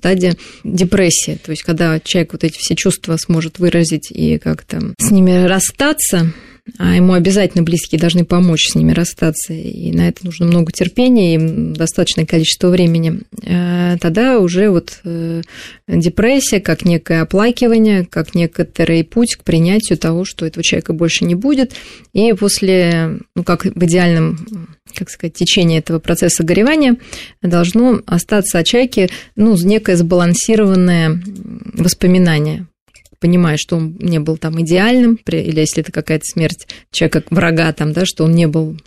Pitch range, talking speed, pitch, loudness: 165-195 Hz, 150 wpm, 175 Hz, -13 LUFS